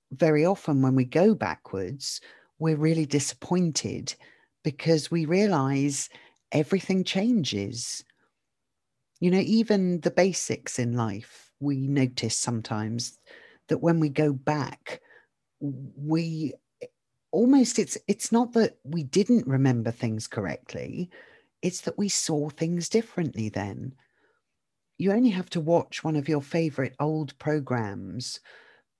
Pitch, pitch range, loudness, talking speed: 155 Hz, 130-180 Hz, -26 LUFS, 120 wpm